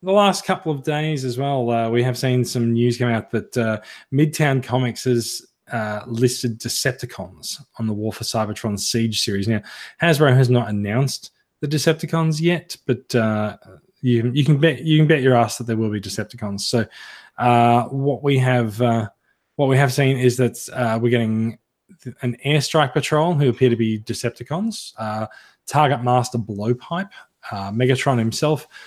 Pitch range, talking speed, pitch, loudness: 115-145 Hz, 175 wpm, 125 Hz, -20 LUFS